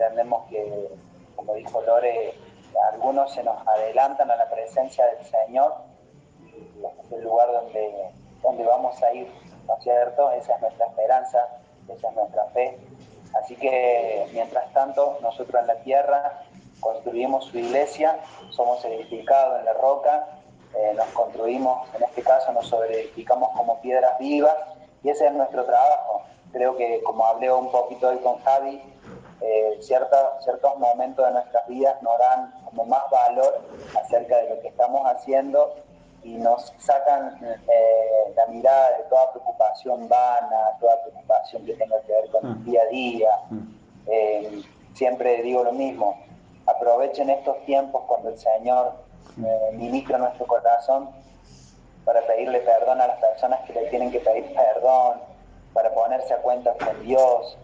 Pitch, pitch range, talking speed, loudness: 125 Hz, 115-135 Hz, 150 wpm, -22 LUFS